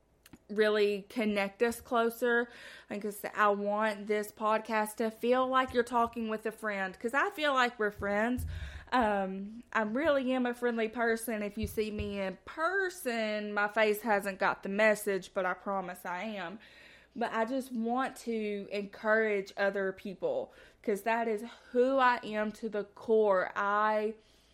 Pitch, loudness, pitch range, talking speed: 215 Hz, -32 LUFS, 205-235 Hz, 165 wpm